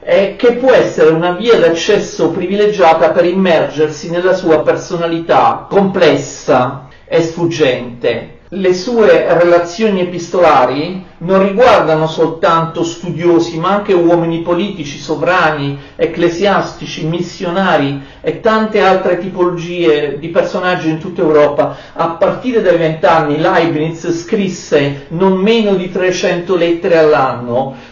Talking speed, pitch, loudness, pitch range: 110 wpm, 170 Hz, -12 LUFS, 160-190 Hz